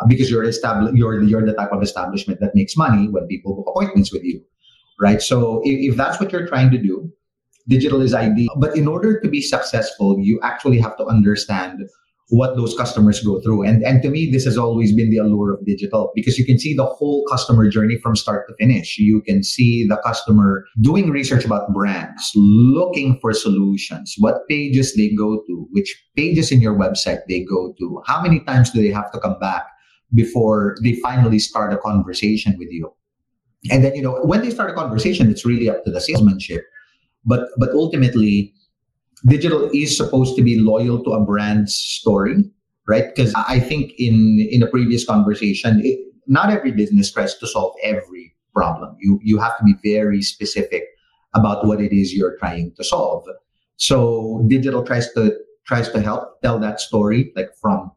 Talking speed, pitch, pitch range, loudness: 195 wpm, 115 Hz, 105-135 Hz, -17 LUFS